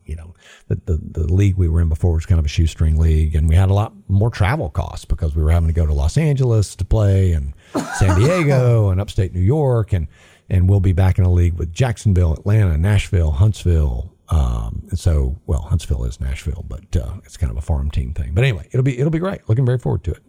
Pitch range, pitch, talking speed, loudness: 80-105 Hz, 90 Hz, 245 wpm, -18 LUFS